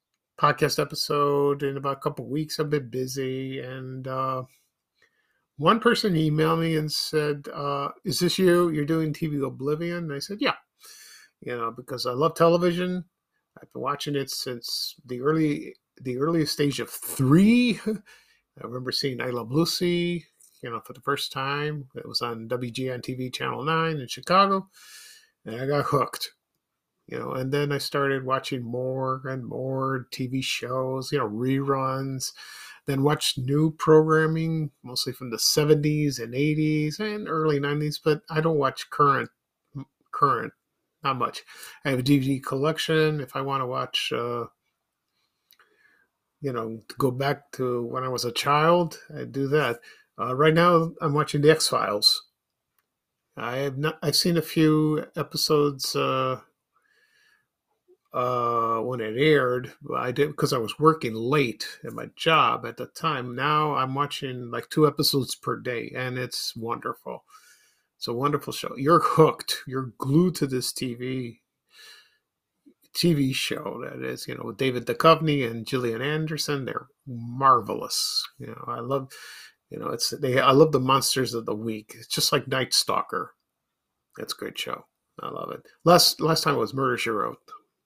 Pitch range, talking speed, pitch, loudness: 130-155 Hz, 165 wpm, 145 Hz, -25 LUFS